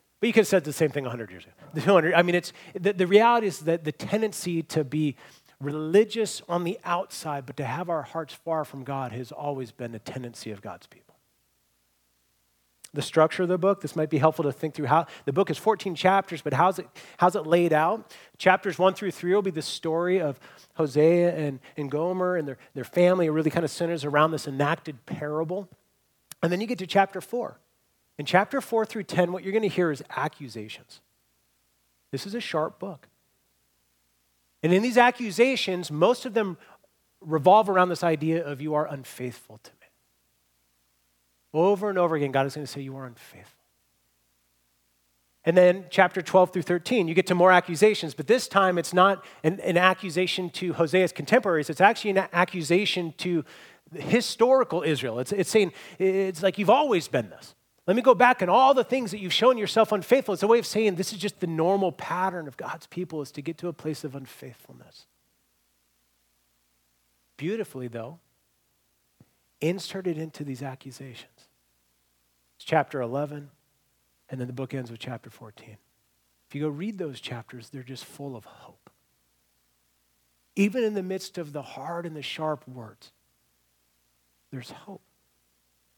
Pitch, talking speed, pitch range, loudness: 160 Hz, 180 wpm, 120-185 Hz, -25 LUFS